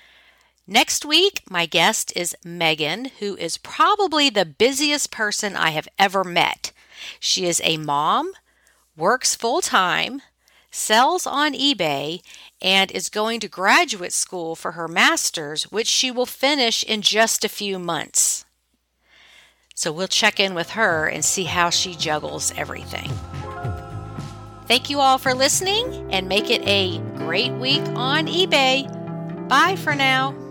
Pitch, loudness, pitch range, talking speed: 210 Hz, -19 LUFS, 170-270 Hz, 140 wpm